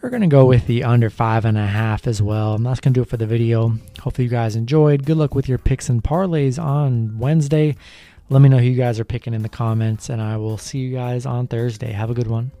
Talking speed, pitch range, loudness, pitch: 265 wpm, 110-135 Hz, -18 LUFS, 120 Hz